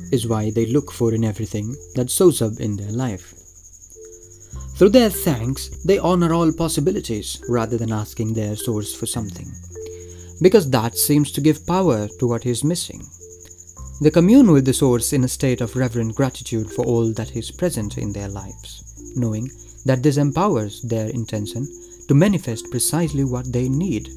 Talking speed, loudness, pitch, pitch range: 170 wpm, -19 LUFS, 115 Hz, 105-140 Hz